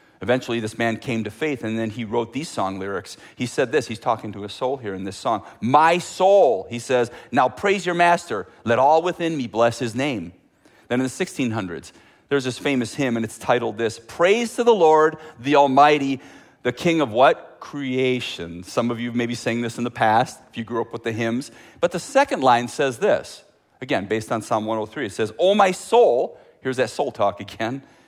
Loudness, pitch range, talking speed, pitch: -21 LUFS, 115-155 Hz, 215 wpm, 125 Hz